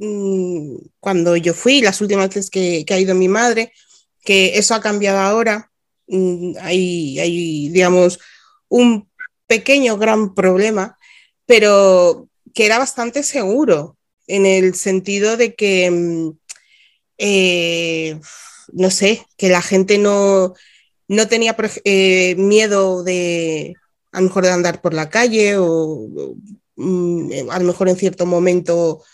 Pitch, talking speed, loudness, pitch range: 190 Hz, 130 wpm, -15 LUFS, 180-215 Hz